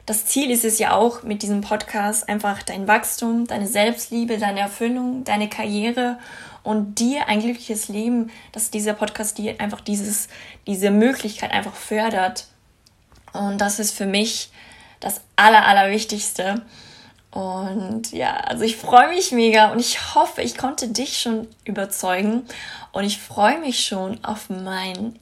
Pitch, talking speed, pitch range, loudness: 215 Hz, 150 wpm, 205-235 Hz, -20 LUFS